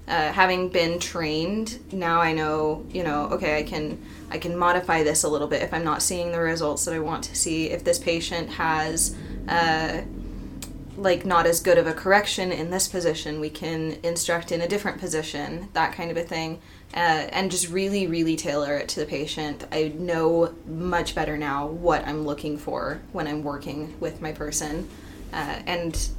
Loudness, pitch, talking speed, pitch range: -25 LUFS, 165 Hz, 190 wpm, 155-175 Hz